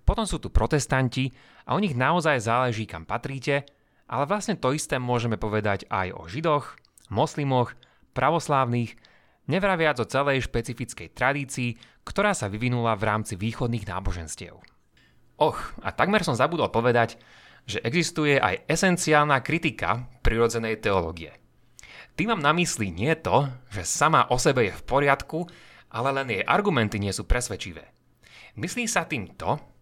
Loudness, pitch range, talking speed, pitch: -25 LUFS, 110-150 Hz, 145 wpm, 125 Hz